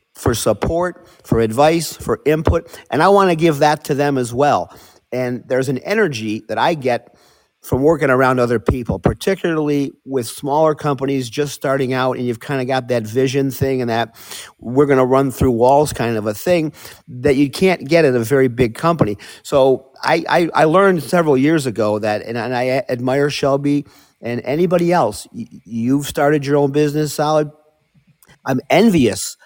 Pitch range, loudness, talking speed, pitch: 125-155 Hz, -17 LUFS, 180 wpm, 140 Hz